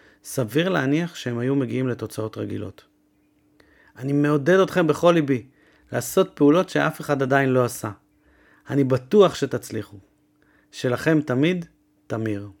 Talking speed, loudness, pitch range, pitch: 120 wpm, -22 LUFS, 110-150 Hz, 140 Hz